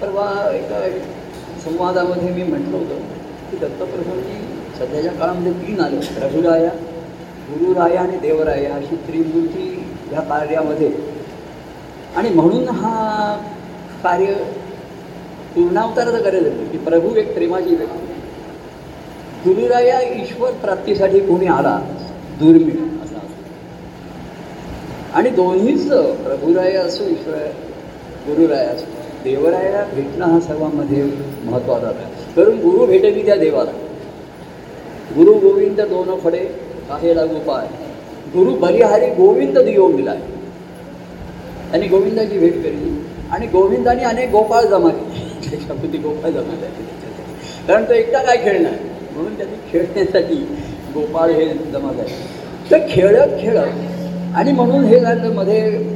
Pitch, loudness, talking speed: 195 Hz, -16 LUFS, 110 wpm